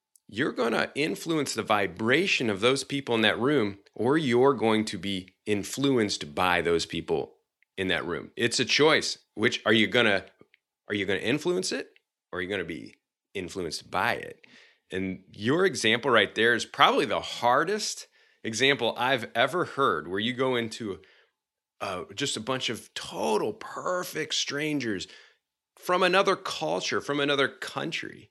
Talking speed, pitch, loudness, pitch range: 165 wpm, 125 Hz, -26 LUFS, 105-145 Hz